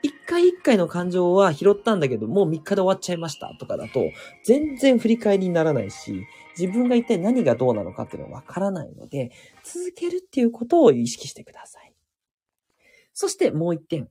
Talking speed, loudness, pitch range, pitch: 405 characters per minute, -22 LUFS, 170-270 Hz, 200 Hz